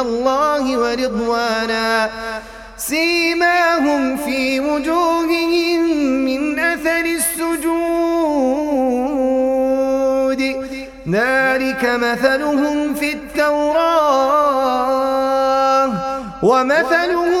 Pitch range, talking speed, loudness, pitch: 260-320 Hz, 45 wpm, -16 LUFS, 270 Hz